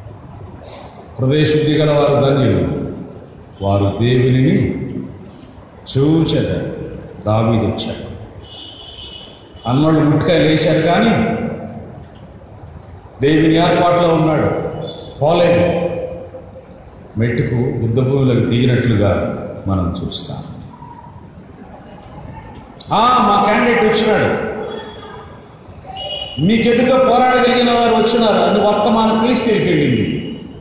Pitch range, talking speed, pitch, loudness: 105-175 Hz, 60 wpm, 140 Hz, -14 LUFS